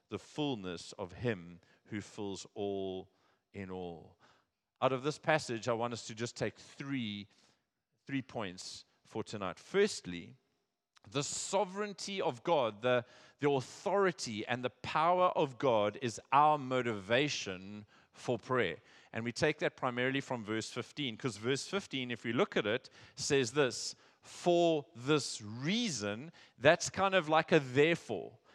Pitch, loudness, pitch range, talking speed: 125 Hz, -34 LUFS, 105-150 Hz, 145 wpm